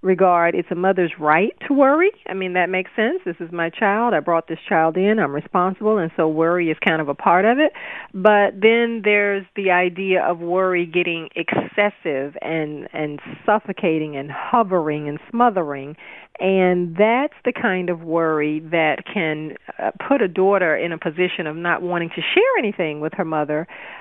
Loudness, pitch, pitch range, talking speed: -19 LUFS, 180 Hz, 160-205 Hz, 180 wpm